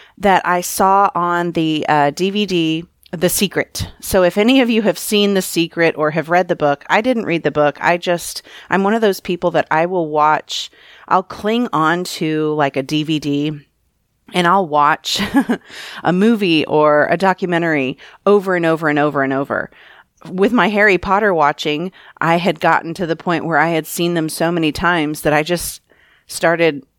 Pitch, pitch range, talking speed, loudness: 170 Hz, 150-185 Hz, 185 wpm, -16 LUFS